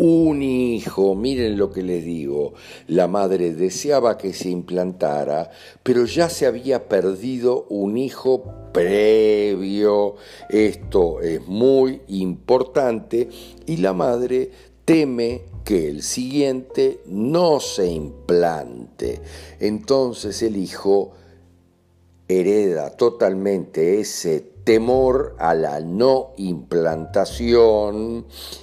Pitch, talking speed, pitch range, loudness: 105 Hz, 95 wpm, 90-125 Hz, -20 LUFS